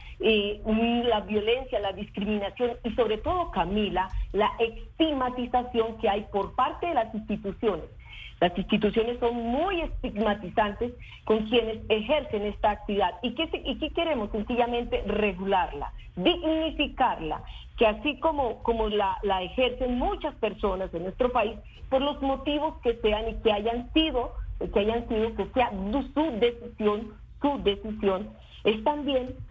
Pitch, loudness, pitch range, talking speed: 230 Hz, -27 LUFS, 210-260 Hz, 140 wpm